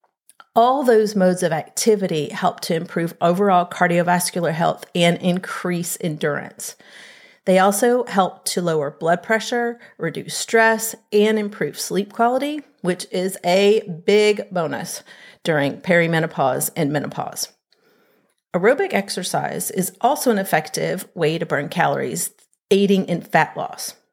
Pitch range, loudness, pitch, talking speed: 170-225 Hz, -20 LUFS, 185 Hz, 125 wpm